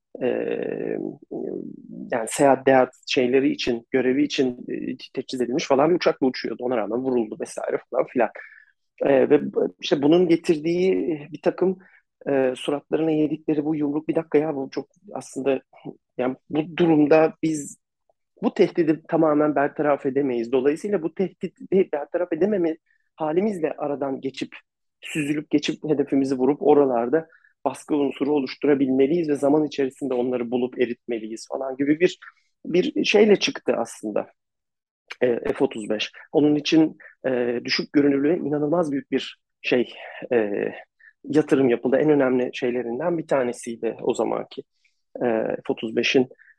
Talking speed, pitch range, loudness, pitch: 120 wpm, 130-160 Hz, -23 LUFS, 145 Hz